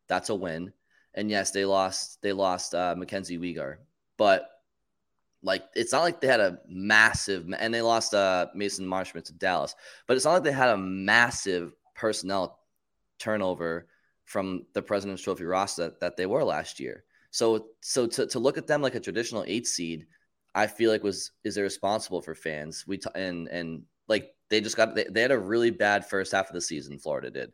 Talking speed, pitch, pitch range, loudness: 195 wpm, 95 Hz, 90-105 Hz, -27 LUFS